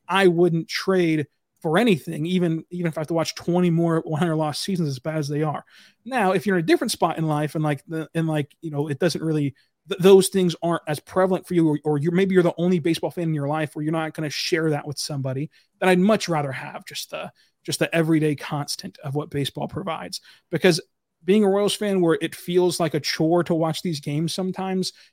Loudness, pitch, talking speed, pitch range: -23 LUFS, 165 Hz, 240 wpm, 155-180 Hz